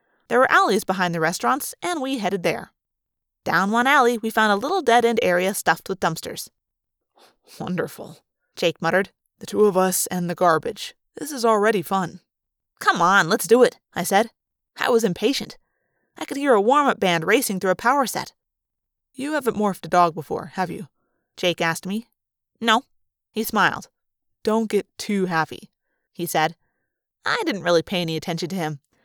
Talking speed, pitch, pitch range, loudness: 180 wpm, 195 Hz, 175-230 Hz, -21 LUFS